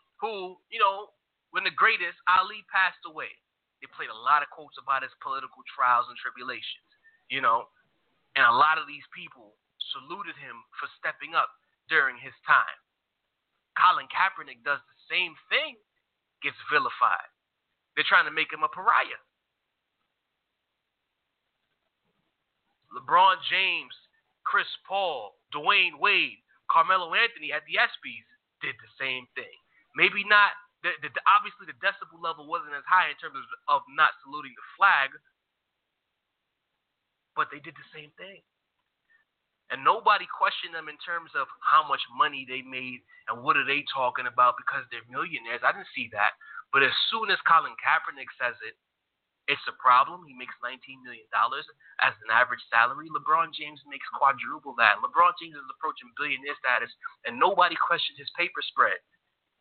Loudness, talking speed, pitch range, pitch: -26 LUFS, 155 wpm, 150-230 Hz, 180 Hz